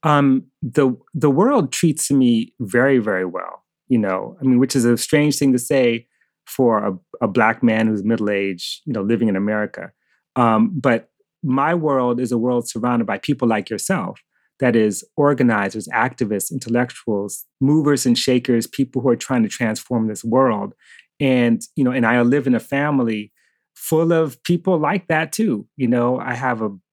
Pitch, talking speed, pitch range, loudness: 125 Hz, 180 wpm, 115-145 Hz, -19 LUFS